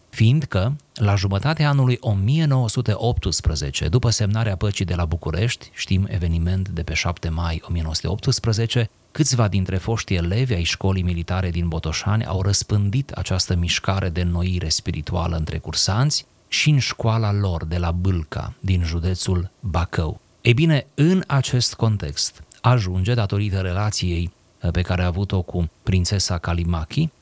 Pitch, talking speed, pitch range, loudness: 95 Hz, 135 wpm, 85-115 Hz, -21 LUFS